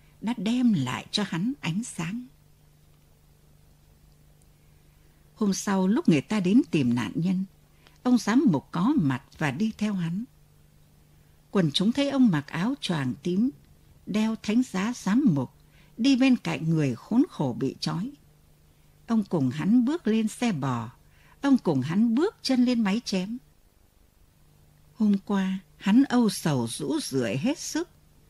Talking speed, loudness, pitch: 150 wpm, -26 LUFS, 195 Hz